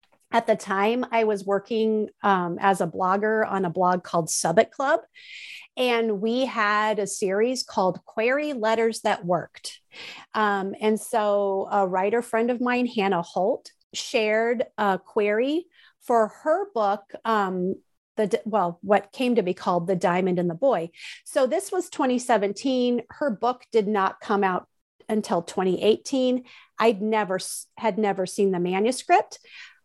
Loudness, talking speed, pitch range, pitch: -24 LUFS, 150 wpm, 195-245 Hz, 215 Hz